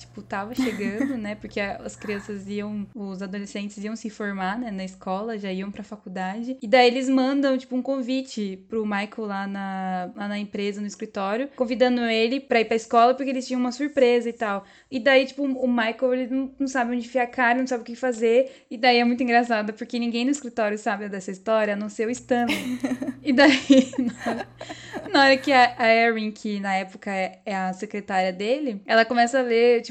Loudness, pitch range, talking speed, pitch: -23 LUFS, 205-255 Hz, 210 wpm, 235 Hz